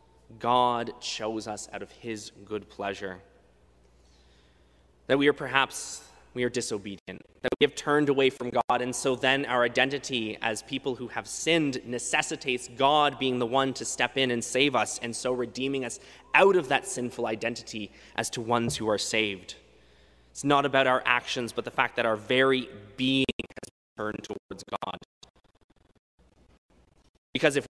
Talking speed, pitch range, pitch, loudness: 165 wpm, 105-130 Hz, 120 Hz, -27 LUFS